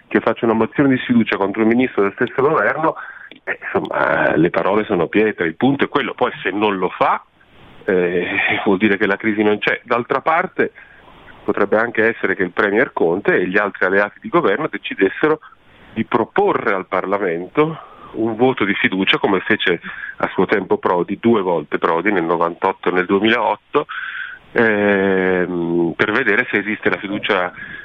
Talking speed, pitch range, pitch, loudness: 170 wpm, 95-120 Hz, 105 Hz, -17 LUFS